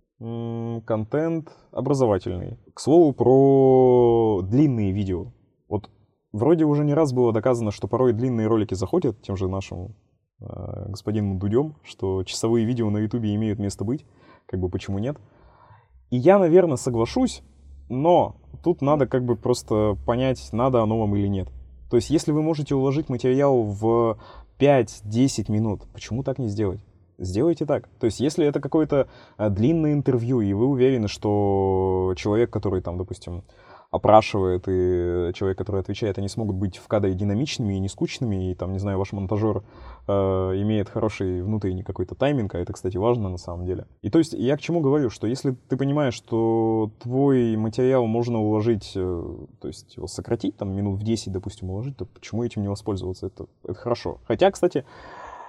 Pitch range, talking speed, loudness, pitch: 95-130 Hz, 165 wpm, -23 LUFS, 110 Hz